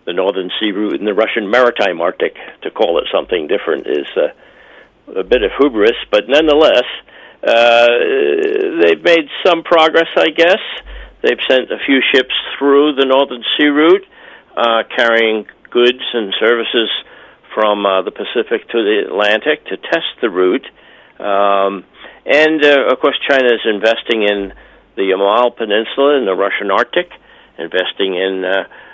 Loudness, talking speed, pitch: -13 LUFS, 155 wpm, 140 Hz